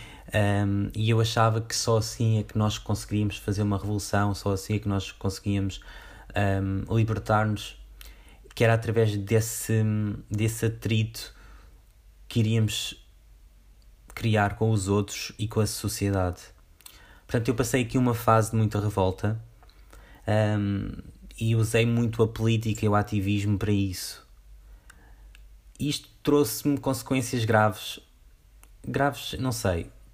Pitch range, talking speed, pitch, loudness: 100-115 Hz, 130 wpm, 105 Hz, -26 LUFS